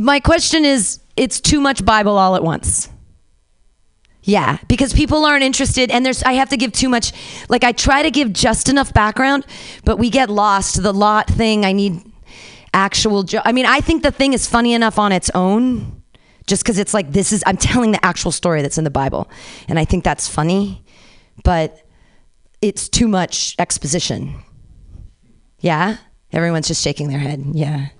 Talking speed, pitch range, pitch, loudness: 185 wpm, 175-255 Hz, 210 Hz, -15 LUFS